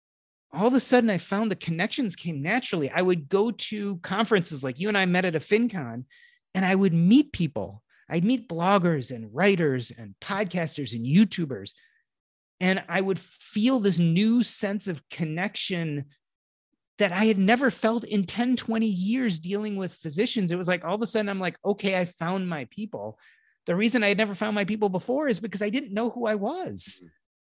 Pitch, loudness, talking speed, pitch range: 195 Hz, -25 LUFS, 195 wpm, 170-220 Hz